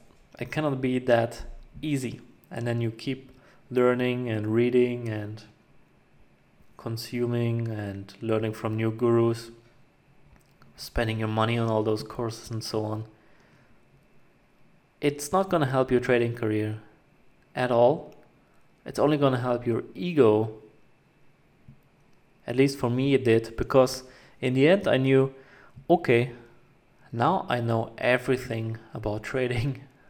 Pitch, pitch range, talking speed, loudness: 120 Hz, 110-130 Hz, 130 wpm, -26 LUFS